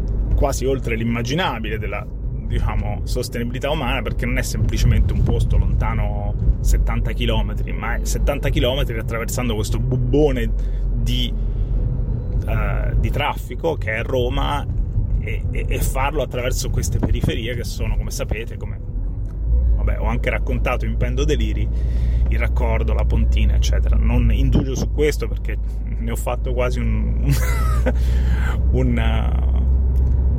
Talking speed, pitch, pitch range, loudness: 130 wpm, 110 Hz, 85-120 Hz, -21 LUFS